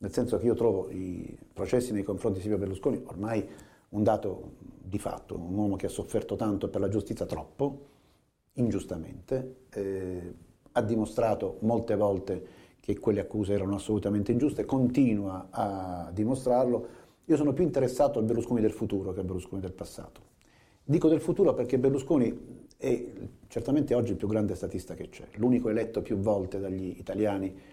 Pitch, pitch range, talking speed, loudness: 105 Hz, 95-125 Hz, 160 wpm, -30 LUFS